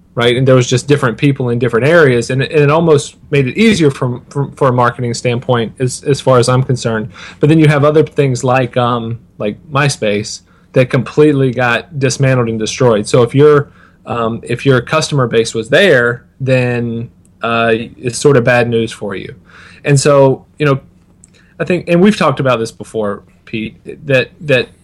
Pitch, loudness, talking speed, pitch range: 125 Hz, -12 LUFS, 195 wpm, 115-140 Hz